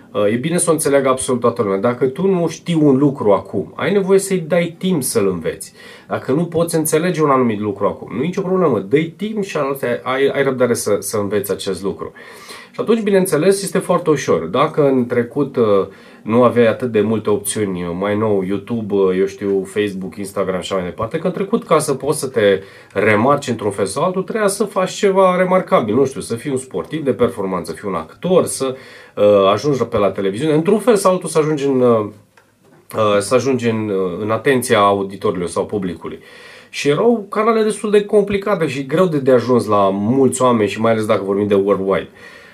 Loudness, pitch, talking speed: -17 LUFS, 130 Hz, 200 wpm